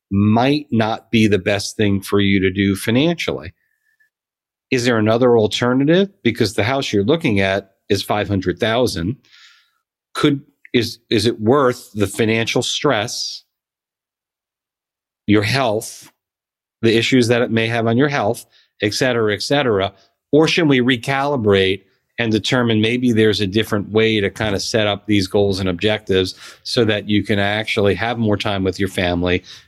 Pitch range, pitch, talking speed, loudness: 100-125 Hz, 110 Hz, 160 wpm, -17 LUFS